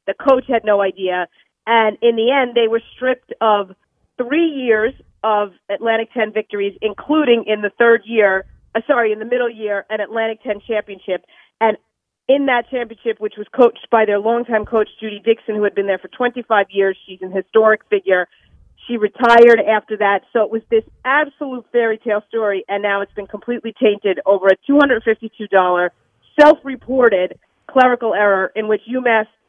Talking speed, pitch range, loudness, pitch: 175 wpm, 205-235 Hz, -16 LUFS, 220 Hz